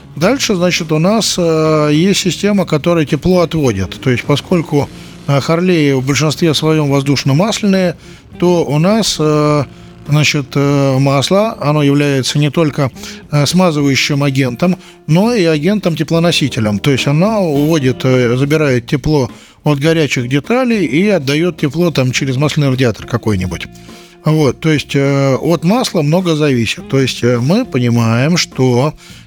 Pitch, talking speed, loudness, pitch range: 150 Hz, 125 wpm, -13 LUFS, 140-175 Hz